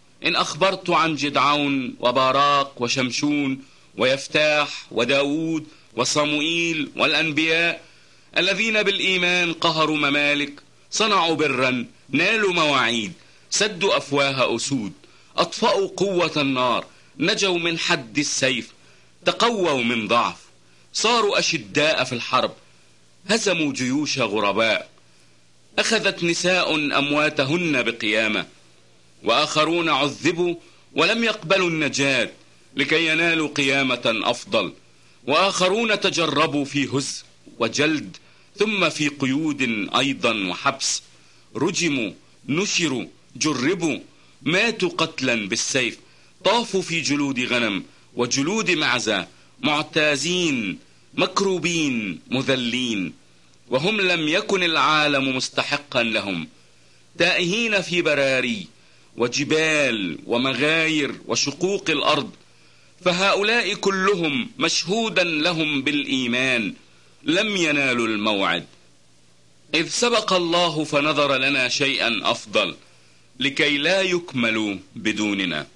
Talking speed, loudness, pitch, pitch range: 85 wpm, -21 LUFS, 145 Hz, 125-175 Hz